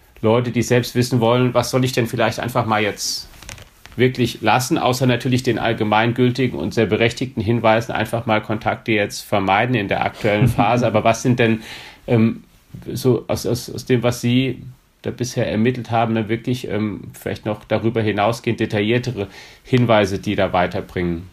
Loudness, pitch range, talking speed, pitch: -19 LUFS, 110-125 Hz, 170 wpm, 115 Hz